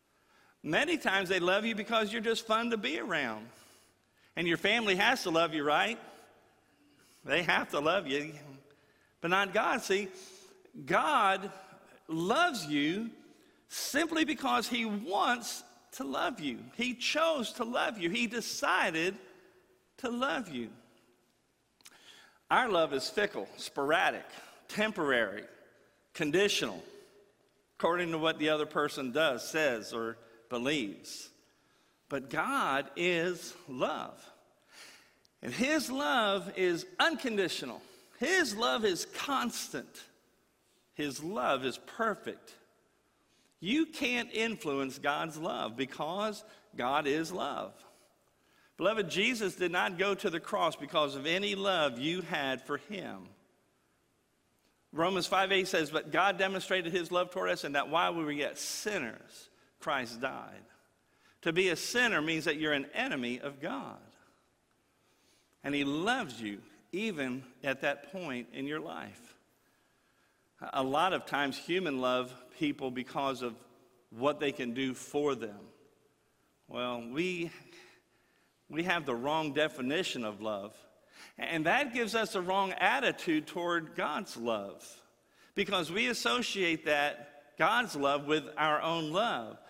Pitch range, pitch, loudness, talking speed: 145-215 Hz, 175 Hz, -32 LUFS, 130 wpm